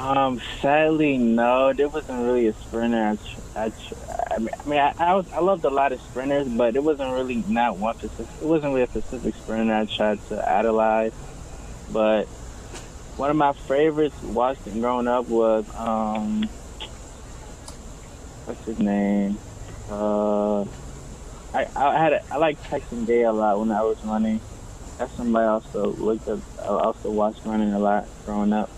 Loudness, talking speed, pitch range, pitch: -23 LUFS, 170 wpm, 105-130 Hz, 110 Hz